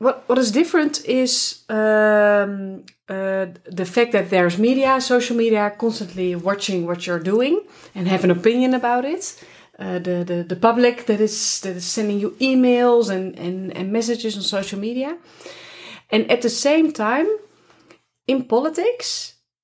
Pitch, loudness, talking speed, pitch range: 220 Hz, -19 LUFS, 155 wpm, 190-255 Hz